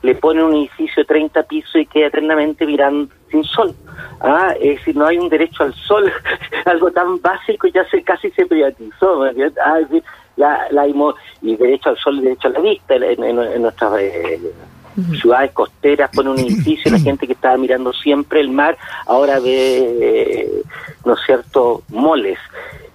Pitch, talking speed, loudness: 170 Hz, 185 wpm, -15 LUFS